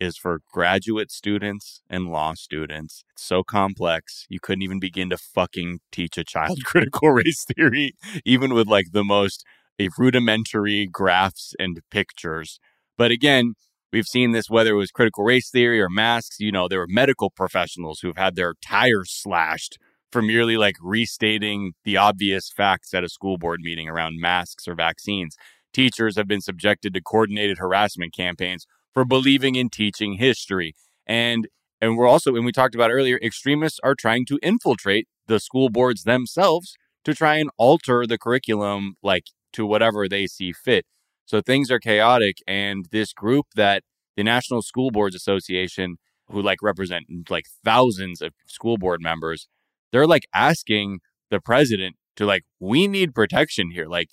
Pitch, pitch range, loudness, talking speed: 105 Hz, 95-120 Hz, -21 LUFS, 165 wpm